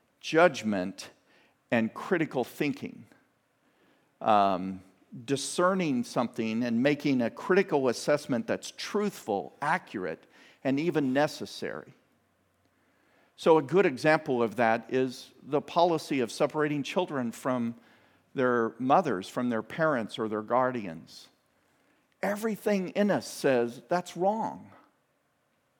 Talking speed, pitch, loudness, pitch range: 105 wpm, 140 Hz, -29 LUFS, 120-175 Hz